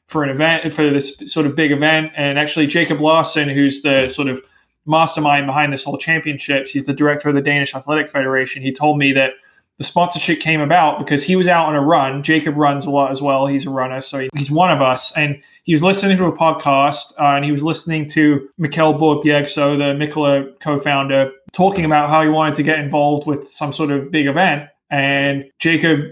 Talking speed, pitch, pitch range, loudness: 215 wpm, 145 Hz, 140-155 Hz, -16 LUFS